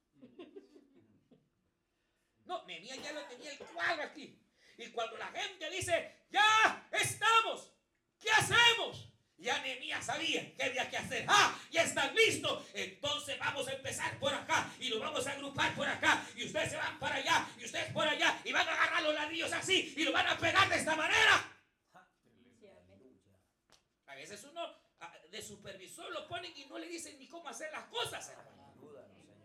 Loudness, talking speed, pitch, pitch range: -32 LUFS, 165 wpm, 310 Hz, 270-350 Hz